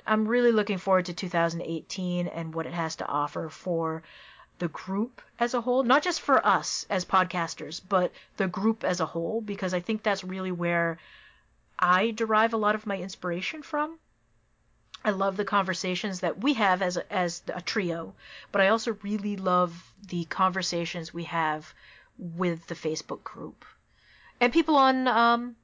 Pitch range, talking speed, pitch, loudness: 170-215 Hz, 170 wpm, 185 Hz, -27 LUFS